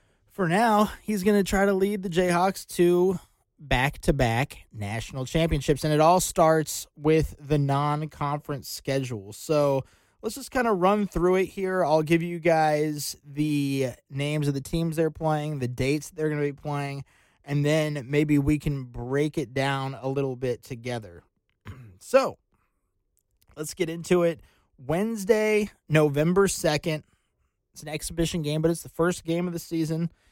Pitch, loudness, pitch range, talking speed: 150 Hz, -25 LUFS, 135-170 Hz, 165 wpm